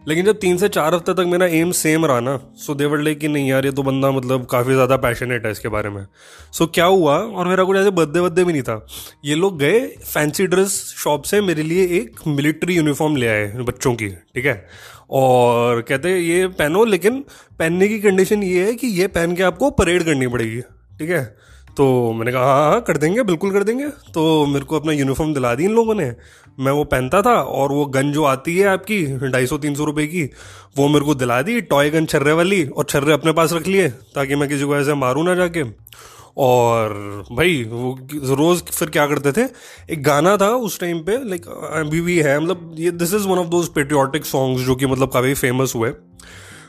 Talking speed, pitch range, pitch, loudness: 220 wpm, 130-180 Hz, 150 Hz, -18 LUFS